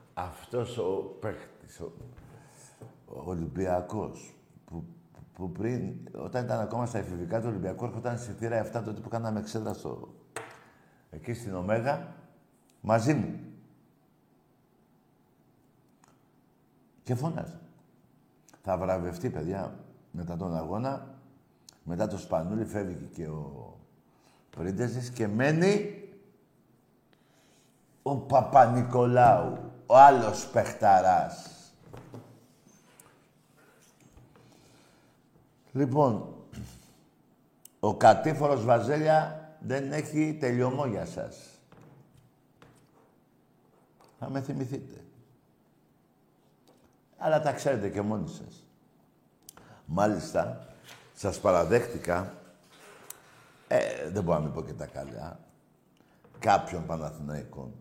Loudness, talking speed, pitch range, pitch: -28 LUFS, 85 wpm, 95-140 Hz, 120 Hz